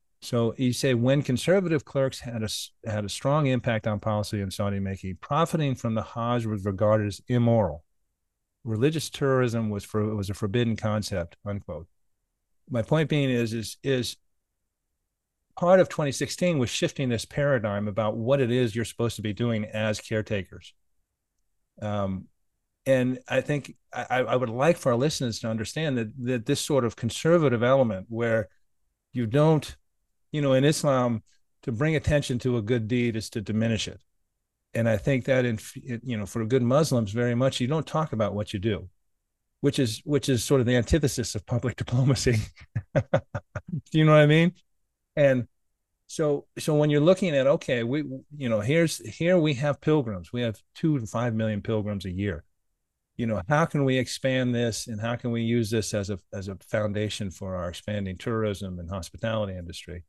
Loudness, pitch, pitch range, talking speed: -26 LUFS, 115 Hz, 100-135 Hz, 180 wpm